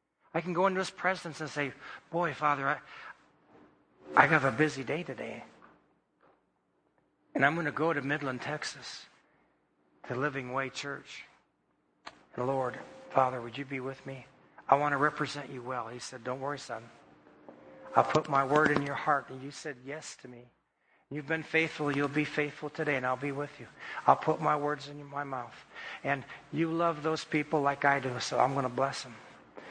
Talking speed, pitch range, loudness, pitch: 190 wpm, 135-155 Hz, -31 LUFS, 145 Hz